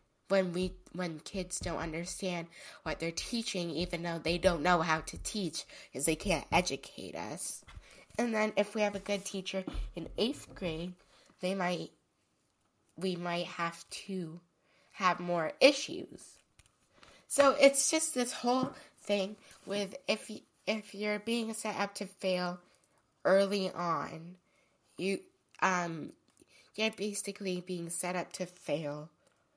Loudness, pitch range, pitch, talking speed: -33 LUFS, 175-205 Hz, 185 Hz, 140 wpm